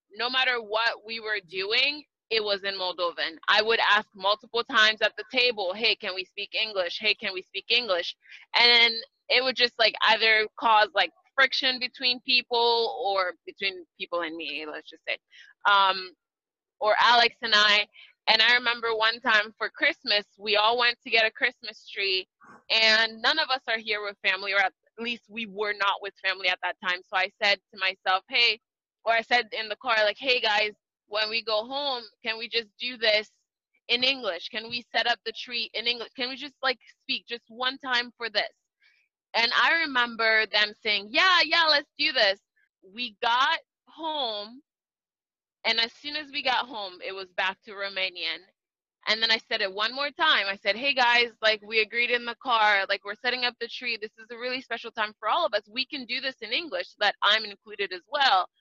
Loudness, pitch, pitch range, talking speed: -25 LUFS, 225 Hz, 205-250 Hz, 205 wpm